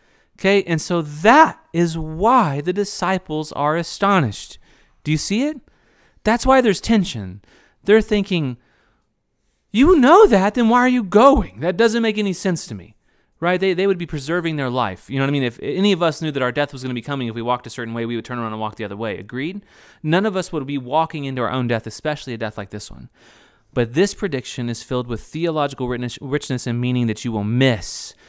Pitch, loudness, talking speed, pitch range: 150 Hz, -19 LUFS, 225 wpm, 120-195 Hz